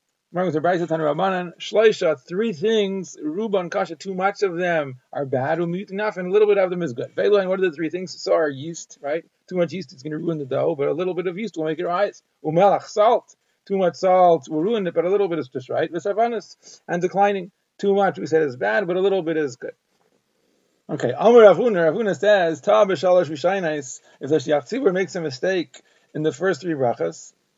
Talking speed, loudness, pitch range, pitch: 185 wpm, -21 LUFS, 160-200 Hz, 180 Hz